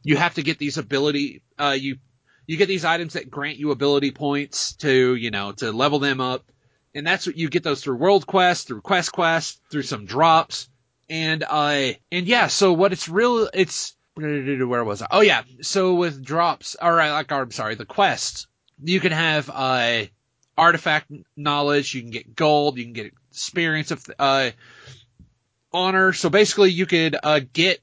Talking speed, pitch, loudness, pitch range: 190 wpm, 145 Hz, -21 LUFS, 130-170 Hz